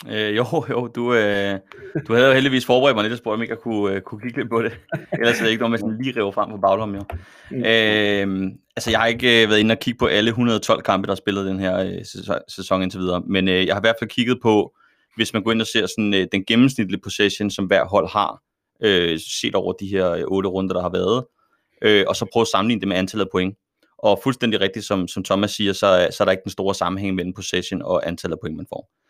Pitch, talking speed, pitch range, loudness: 105 Hz, 260 wpm, 95-115 Hz, -20 LUFS